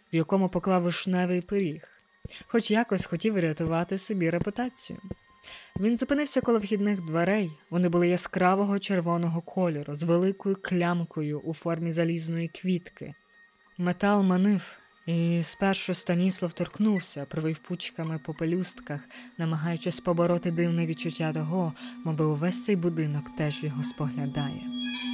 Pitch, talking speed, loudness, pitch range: 175 Hz, 120 wpm, -28 LUFS, 165-195 Hz